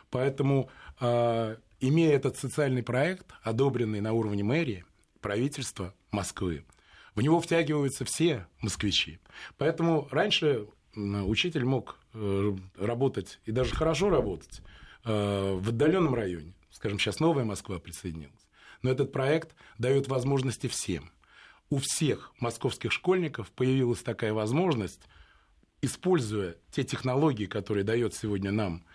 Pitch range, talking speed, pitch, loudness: 100-140 Hz, 110 wpm, 120 Hz, -29 LUFS